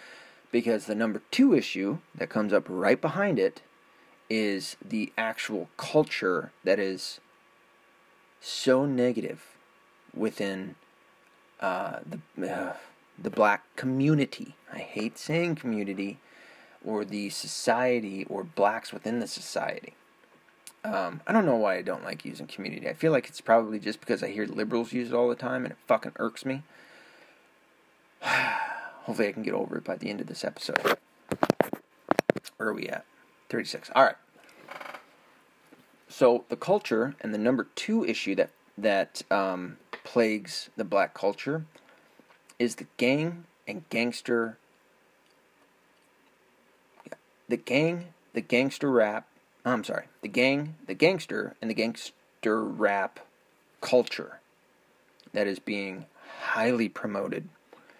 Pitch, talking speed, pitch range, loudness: 120 Hz, 135 wpm, 105-140 Hz, -29 LUFS